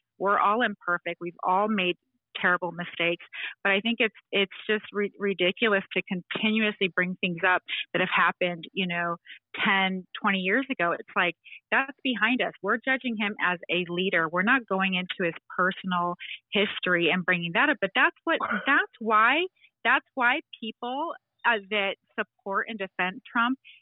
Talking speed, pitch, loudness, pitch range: 165 wpm, 195 Hz, -26 LUFS, 180-235 Hz